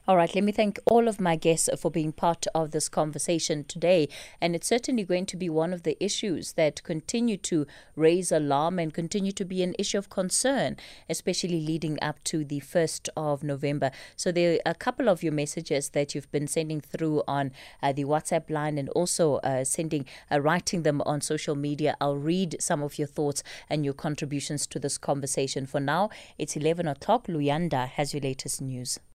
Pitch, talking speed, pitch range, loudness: 160 Hz, 200 wpm, 145-180 Hz, -28 LUFS